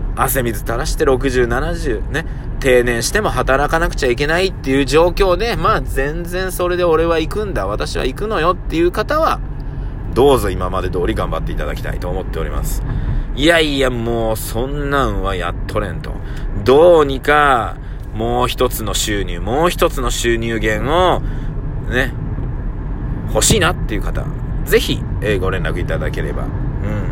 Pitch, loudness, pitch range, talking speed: 130 Hz, -17 LUFS, 110-145 Hz, 305 characters per minute